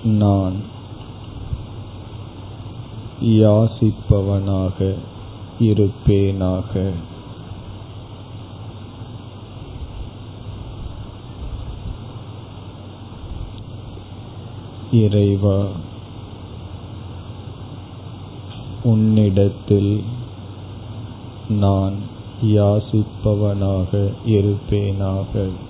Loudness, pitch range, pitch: -19 LUFS, 100-110 Hz, 105 Hz